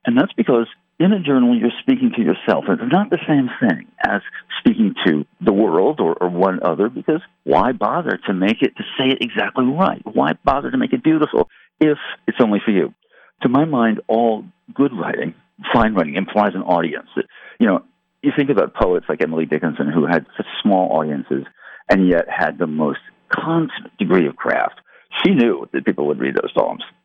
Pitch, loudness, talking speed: 135 Hz, -18 LUFS, 195 wpm